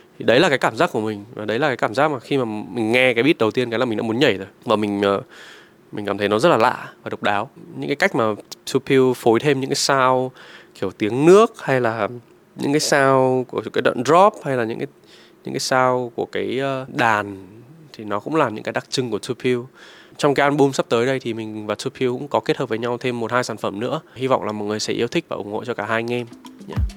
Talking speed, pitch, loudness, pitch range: 270 wpm, 125 Hz, -20 LUFS, 110-135 Hz